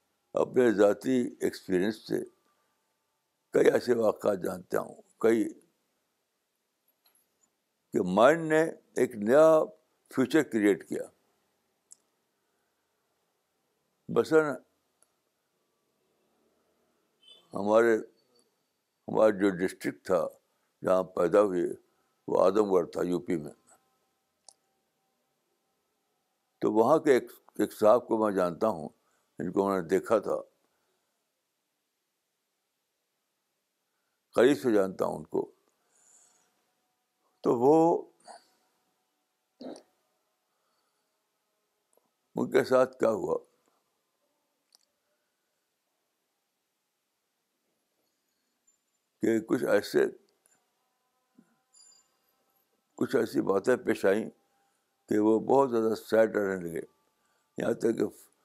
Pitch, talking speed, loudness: 155 Hz, 80 wpm, -27 LUFS